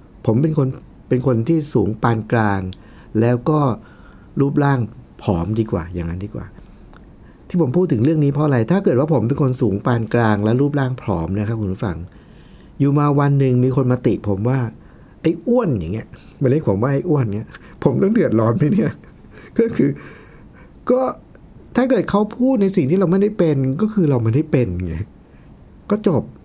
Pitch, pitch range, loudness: 130 Hz, 110-155 Hz, -18 LUFS